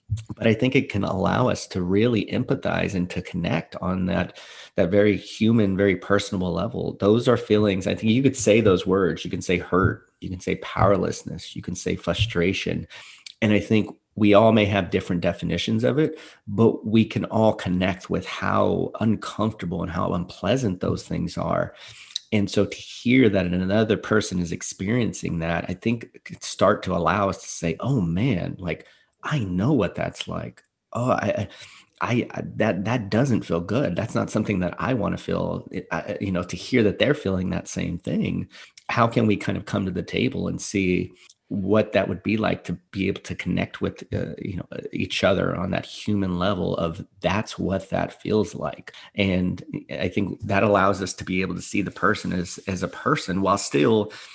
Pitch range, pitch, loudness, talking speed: 90-110 Hz, 100 Hz, -24 LUFS, 200 wpm